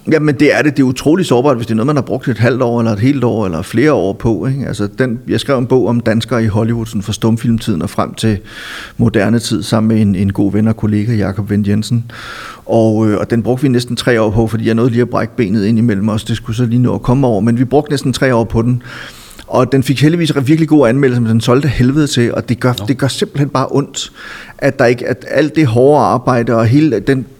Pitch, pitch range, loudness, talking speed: 120 Hz, 110-130 Hz, -13 LUFS, 270 wpm